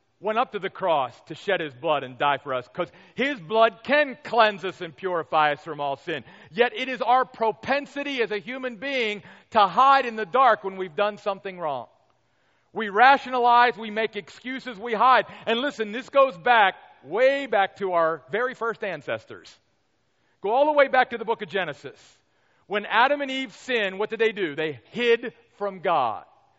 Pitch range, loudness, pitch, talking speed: 185-255 Hz, -24 LUFS, 220 Hz, 195 wpm